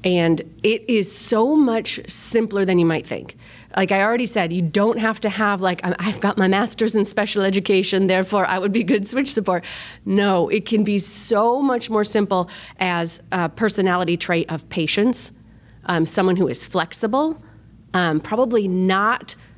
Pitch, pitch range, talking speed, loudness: 195 Hz, 180-220 Hz, 170 wpm, -20 LUFS